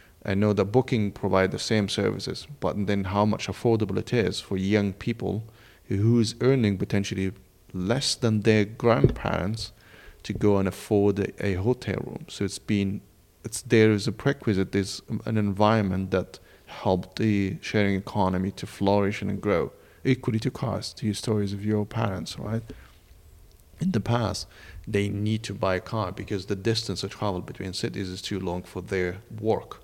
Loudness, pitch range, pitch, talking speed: -26 LUFS, 95-110 Hz, 100 Hz, 170 wpm